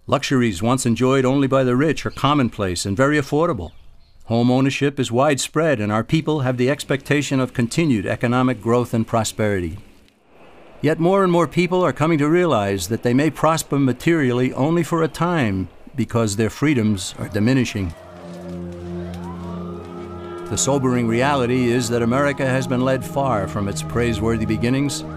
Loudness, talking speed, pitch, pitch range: -19 LUFS, 155 wpm, 125 Hz, 105-140 Hz